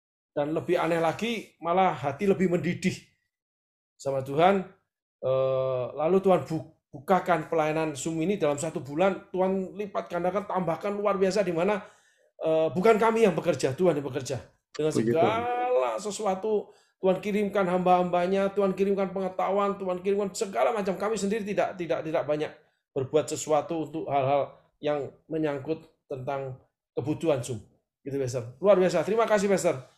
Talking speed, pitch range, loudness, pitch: 140 wpm, 150-195 Hz, -27 LUFS, 175 Hz